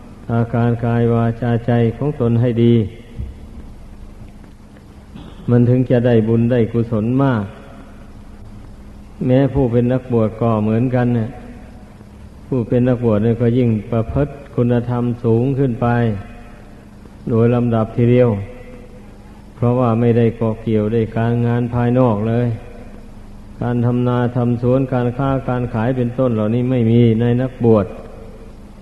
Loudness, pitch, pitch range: -17 LUFS, 120 Hz, 110-125 Hz